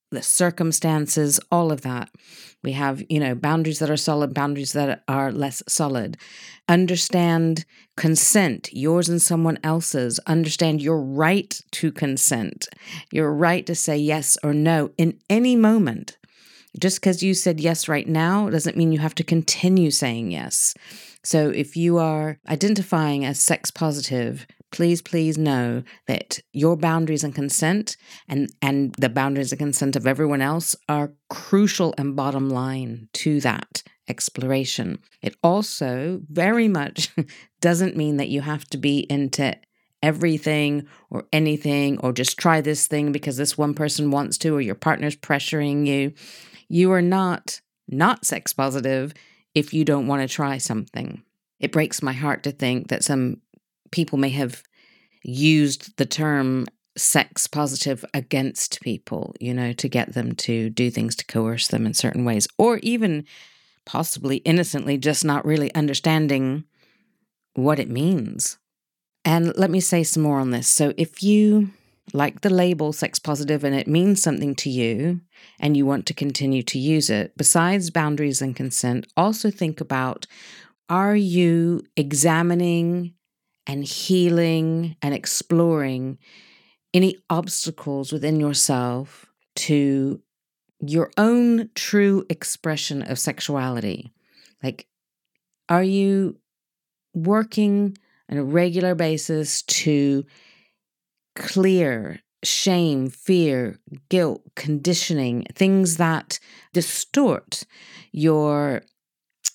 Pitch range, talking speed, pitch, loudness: 140-170 Hz, 135 wpm, 155 Hz, -21 LUFS